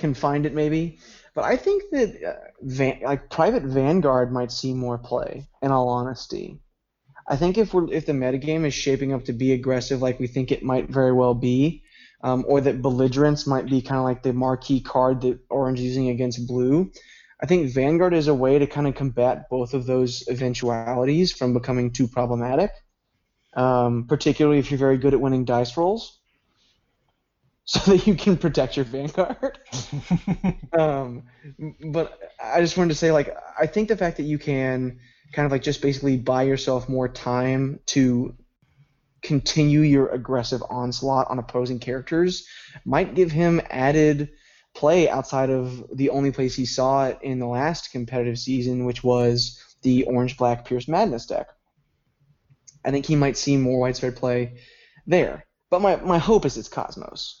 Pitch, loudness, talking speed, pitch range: 135 Hz, -22 LUFS, 175 wpm, 125-150 Hz